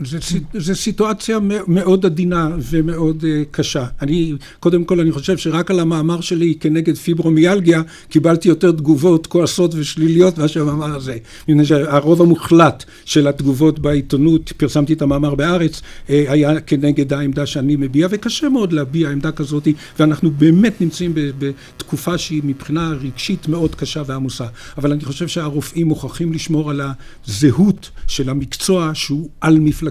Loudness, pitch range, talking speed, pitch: -16 LUFS, 145-170 Hz, 140 wpm, 155 Hz